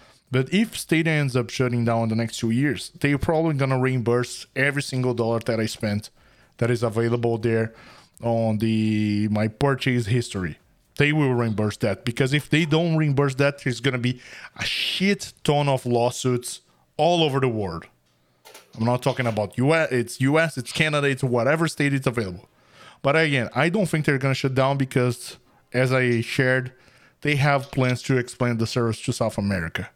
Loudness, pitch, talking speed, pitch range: -23 LUFS, 125 Hz, 180 wpm, 115-140 Hz